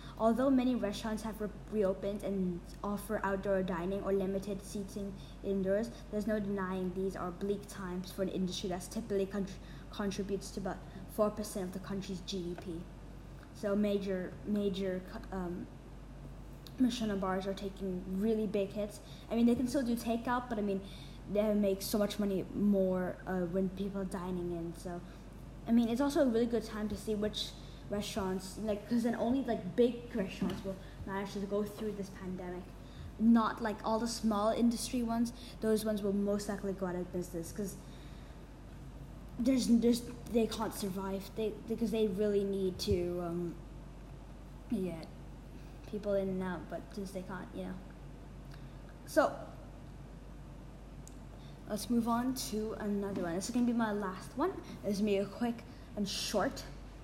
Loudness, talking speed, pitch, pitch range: -35 LUFS, 165 wpm, 200 Hz, 190-220 Hz